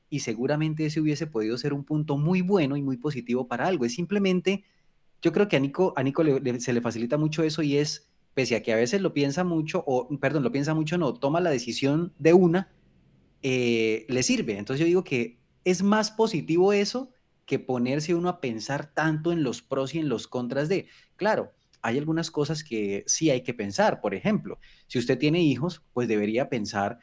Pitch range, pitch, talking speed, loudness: 125-170 Hz, 150 Hz, 210 wpm, -26 LUFS